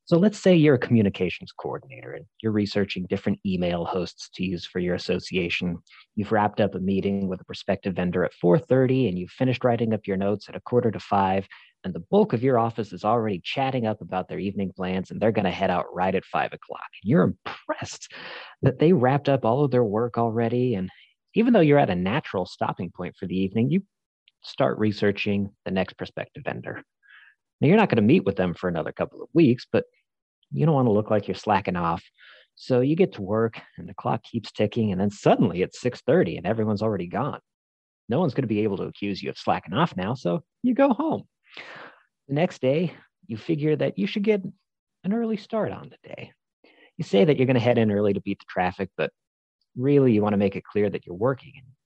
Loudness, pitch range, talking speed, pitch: -24 LUFS, 95-135 Hz, 225 wpm, 110 Hz